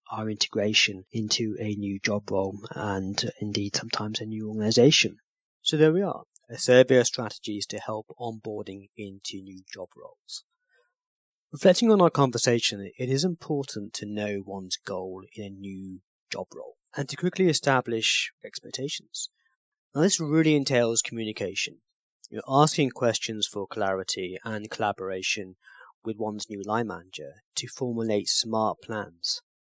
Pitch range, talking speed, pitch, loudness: 100-135 Hz, 140 wpm, 110 Hz, -26 LUFS